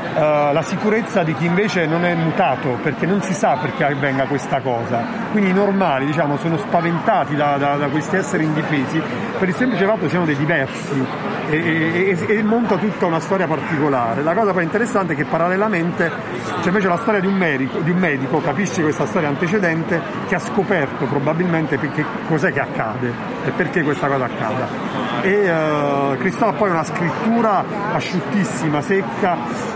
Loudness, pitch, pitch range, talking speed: -19 LUFS, 170 Hz, 150-195 Hz, 175 wpm